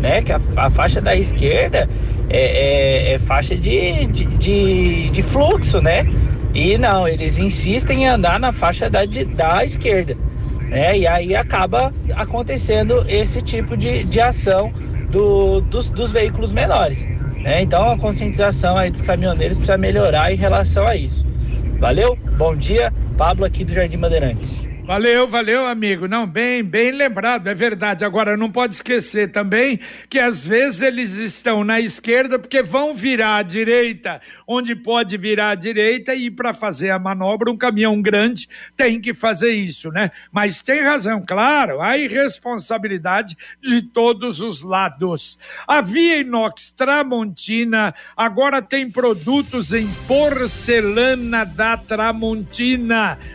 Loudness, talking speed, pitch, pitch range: -17 LUFS, 145 wpm, 225 Hz, 200-245 Hz